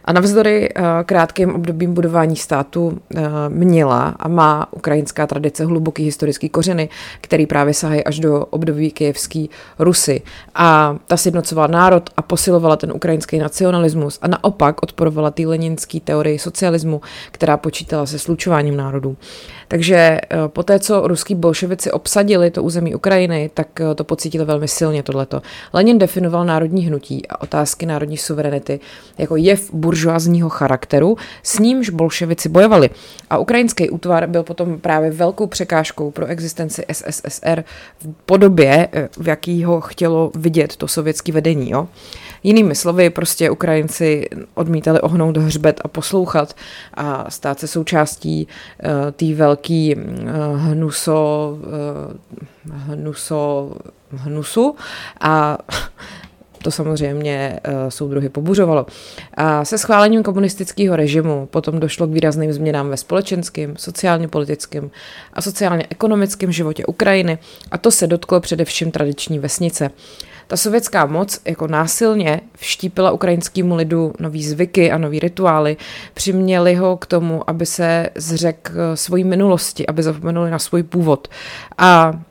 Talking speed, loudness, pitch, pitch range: 135 wpm, -16 LUFS, 160 Hz, 150-175 Hz